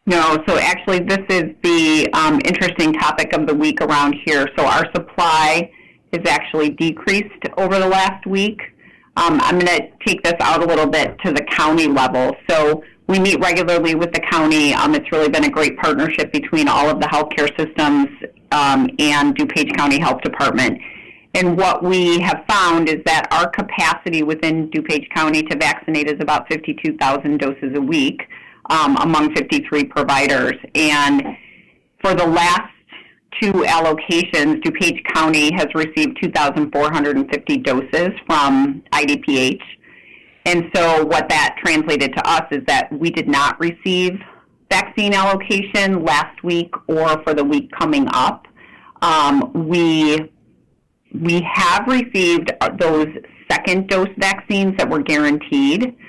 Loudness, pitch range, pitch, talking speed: -16 LUFS, 155-195 Hz, 165 Hz, 145 wpm